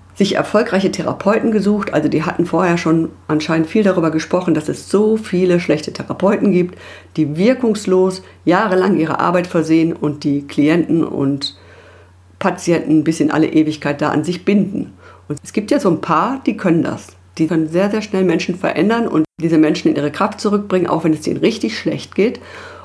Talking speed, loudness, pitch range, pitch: 185 wpm, -16 LUFS, 155-190 Hz, 170 Hz